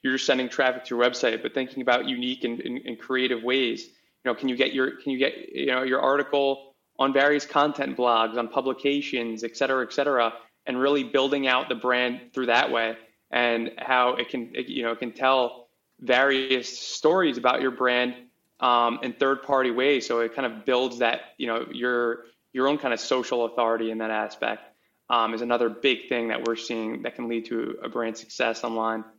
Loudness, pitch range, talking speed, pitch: -25 LUFS, 115-135 Hz, 210 wpm, 125 Hz